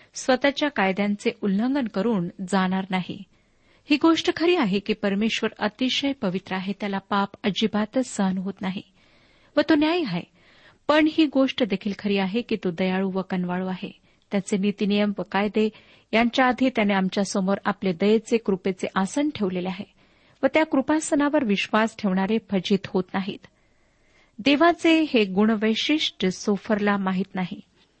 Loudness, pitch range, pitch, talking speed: -24 LUFS, 195-255 Hz, 210 Hz, 135 wpm